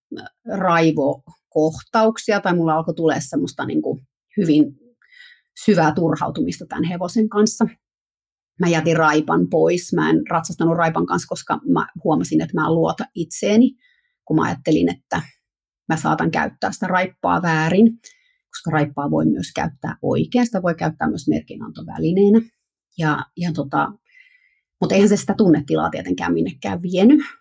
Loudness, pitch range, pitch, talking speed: -19 LUFS, 155-225 Hz, 180 Hz, 135 wpm